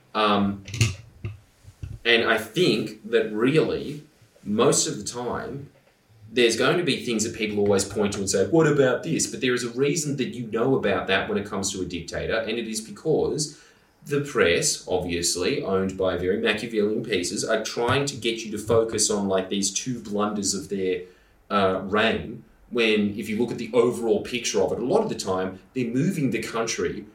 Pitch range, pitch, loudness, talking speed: 95-120 Hz, 110 Hz, -24 LUFS, 195 wpm